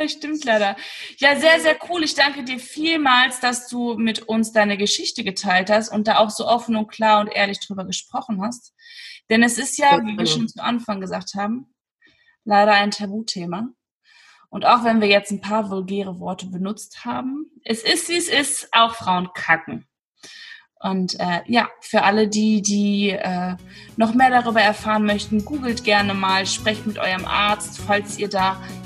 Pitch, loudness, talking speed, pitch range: 215 Hz, -19 LUFS, 180 wpm, 200-250 Hz